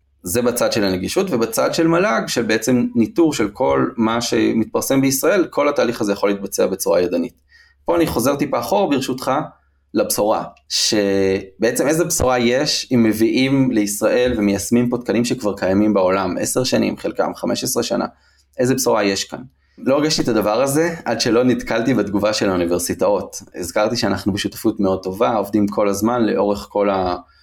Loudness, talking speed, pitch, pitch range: -18 LUFS, 160 wpm, 110 Hz, 100-125 Hz